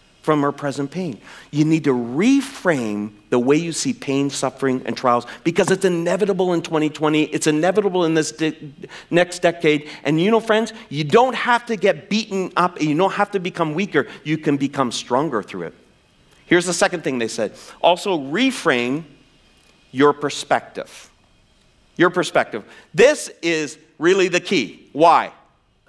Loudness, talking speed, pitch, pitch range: -19 LUFS, 160 wpm, 160 Hz, 145-190 Hz